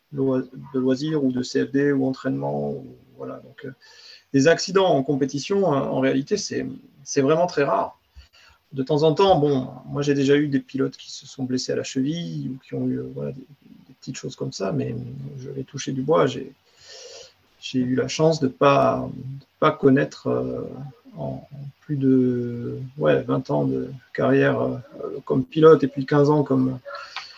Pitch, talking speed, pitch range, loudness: 135 Hz, 190 wpm, 130-145 Hz, -22 LUFS